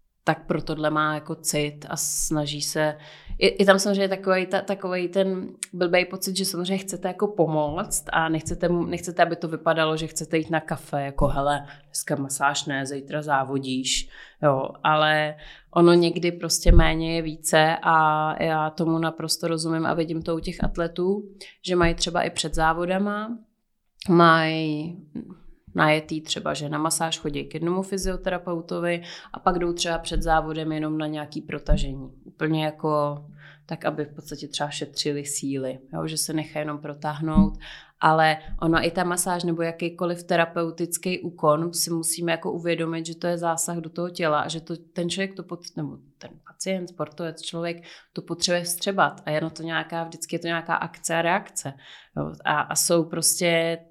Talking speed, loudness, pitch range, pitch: 170 wpm, -24 LUFS, 155-175 Hz, 165 Hz